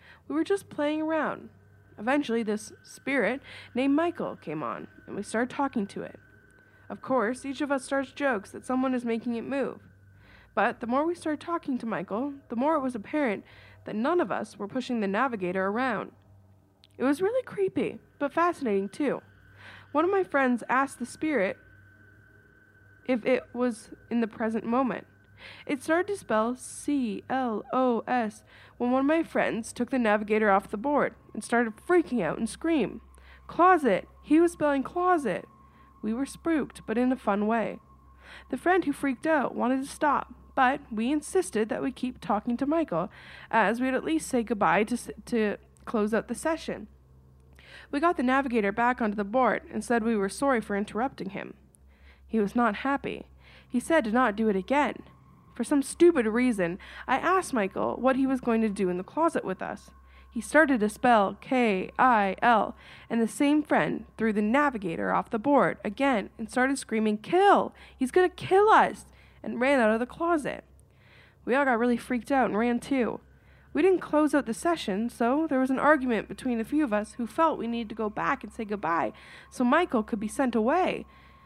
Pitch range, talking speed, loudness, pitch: 215-285 Hz, 190 wpm, -27 LUFS, 245 Hz